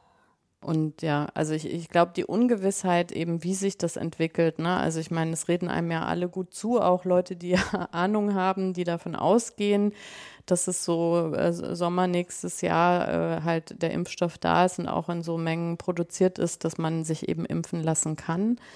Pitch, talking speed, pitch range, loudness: 175 Hz, 190 wpm, 165-185 Hz, -27 LUFS